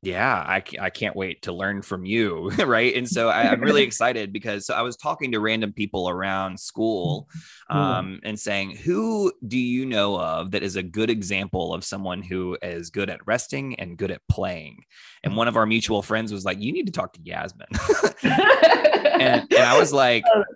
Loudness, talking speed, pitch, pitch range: -22 LUFS, 200 wpm, 105 Hz, 95-115 Hz